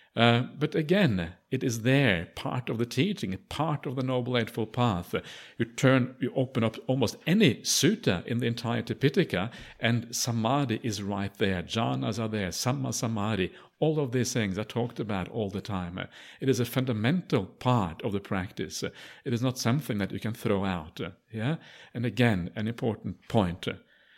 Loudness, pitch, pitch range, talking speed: -29 LUFS, 120 Hz, 105-130 Hz, 175 wpm